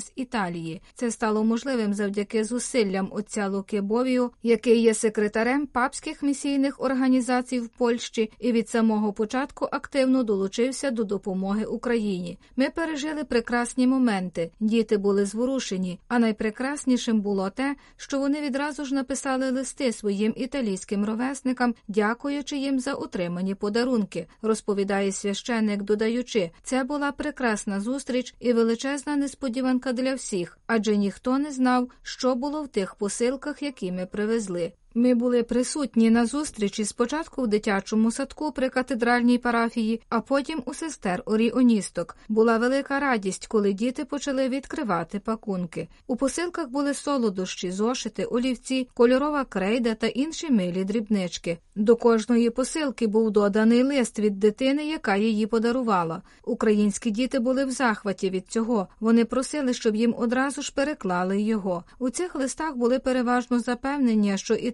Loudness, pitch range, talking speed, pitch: -25 LUFS, 215-265 Hz, 135 wpm, 235 Hz